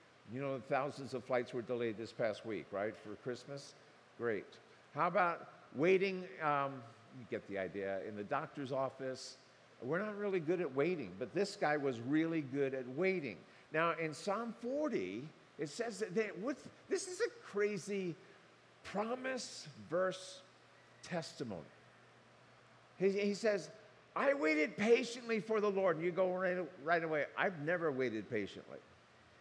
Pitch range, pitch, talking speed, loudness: 135-205 Hz, 170 Hz, 155 wpm, -38 LUFS